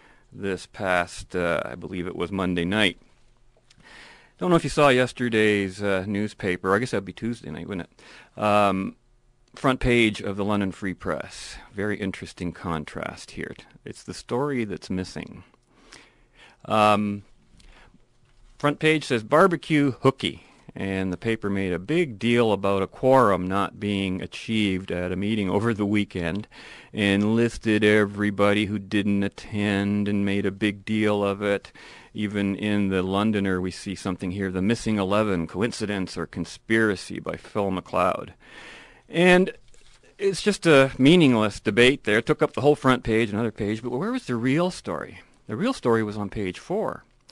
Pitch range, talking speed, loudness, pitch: 95-120 Hz, 160 wpm, -24 LUFS, 105 Hz